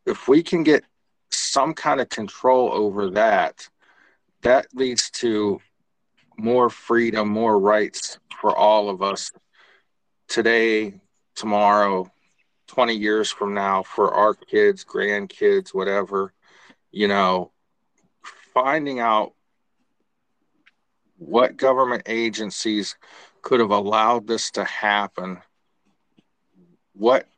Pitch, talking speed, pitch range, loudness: 110 Hz, 100 wpm, 100-125 Hz, -21 LUFS